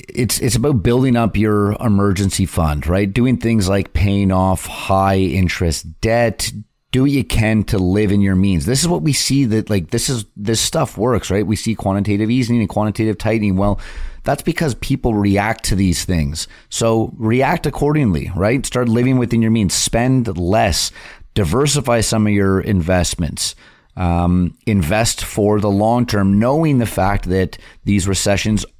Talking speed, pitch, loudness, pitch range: 170 wpm, 105 Hz, -16 LUFS, 95-120 Hz